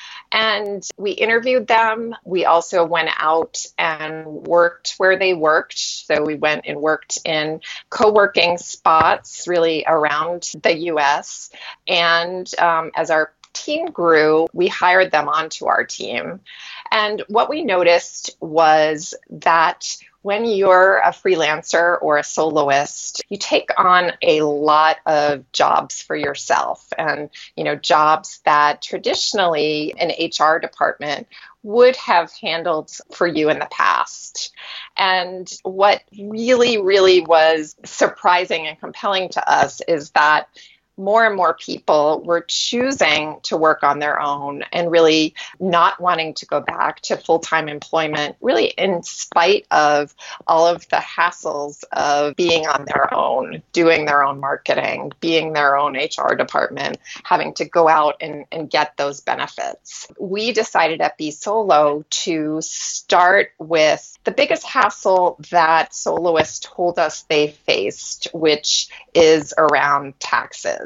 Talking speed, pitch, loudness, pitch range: 140 wpm, 165 Hz, -17 LUFS, 155-190 Hz